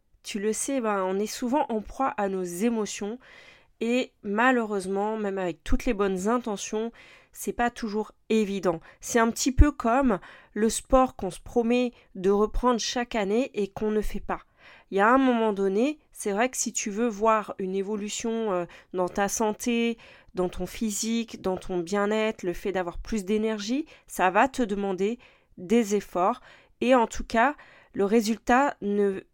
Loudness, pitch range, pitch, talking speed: -27 LUFS, 200-240 Hz, 220 Hz, 175 wpm